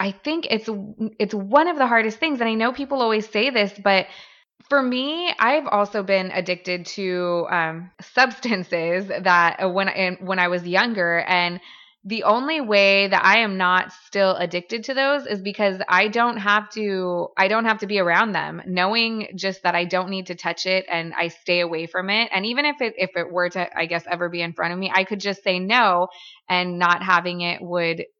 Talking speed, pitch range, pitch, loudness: 210 wpm, 180-220 Hz, 190 Hz, -21 LUFS